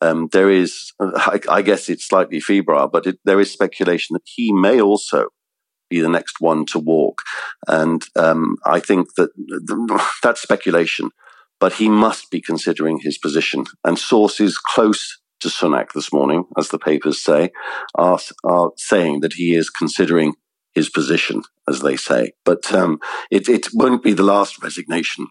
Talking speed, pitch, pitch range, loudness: 165 wpm, 85 Hz, 80-100 Hz, -17 LUFS